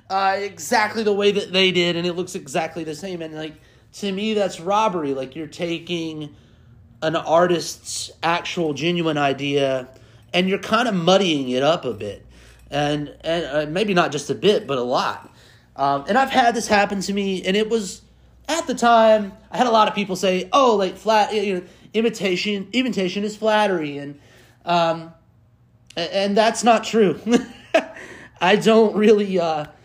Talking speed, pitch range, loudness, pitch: 175 wpm, 150-210 Hz, -20 LUFS, 180 Hz